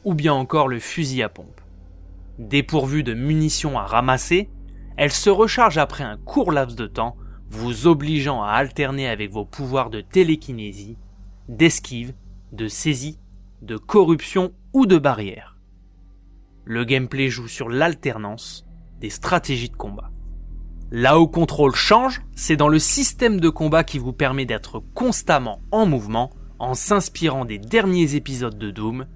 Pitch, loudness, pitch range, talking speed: 130 Hz, -20 LUFS, 105-155 Hz, 145 wpm